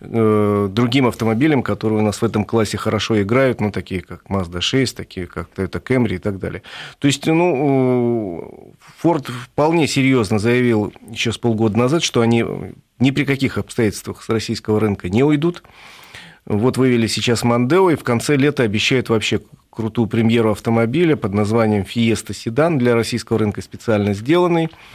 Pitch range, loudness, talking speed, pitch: 105-130 Hz, -18 LUFS, 160 wpm, 115 Hz